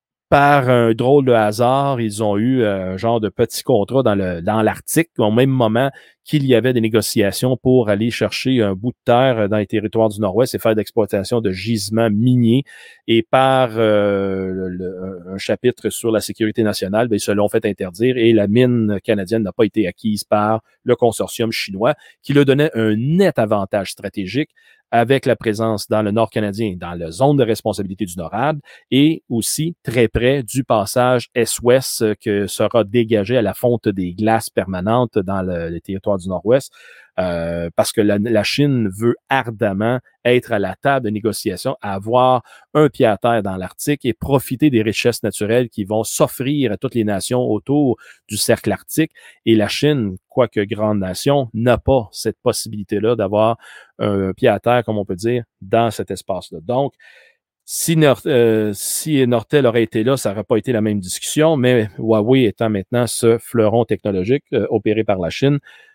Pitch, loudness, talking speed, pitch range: 115 Hz, -17 LUFS, 180 wpm, 105-125 Hz